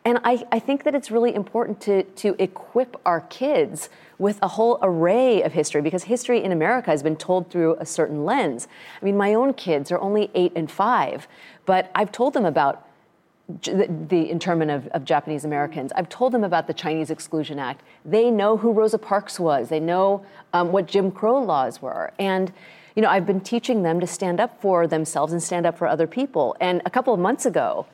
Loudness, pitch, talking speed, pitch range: -22 LUFS, 190 Hz, 210 wpm, 165-225 Hz